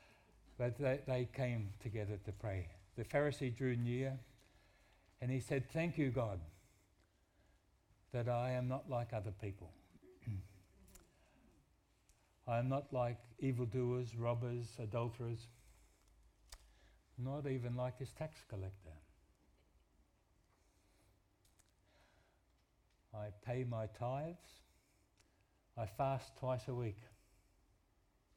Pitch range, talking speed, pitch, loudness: 95-125 Hz, 95 wpm, 110 Hz, -43 LUFS